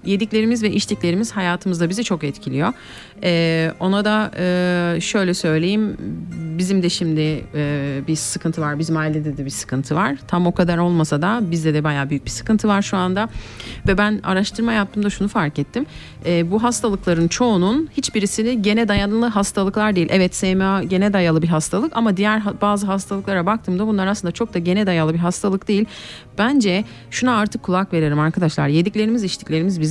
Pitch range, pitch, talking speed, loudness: 165-210 Hz, 185 Hz, 170 wpm, -19 LUFS